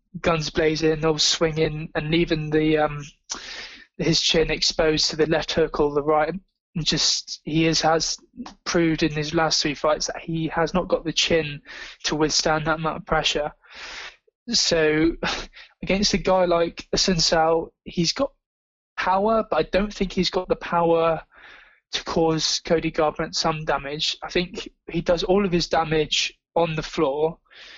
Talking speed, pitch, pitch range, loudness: 160 wpm, 160 Hz, 155-175 Hz, -22 LUFS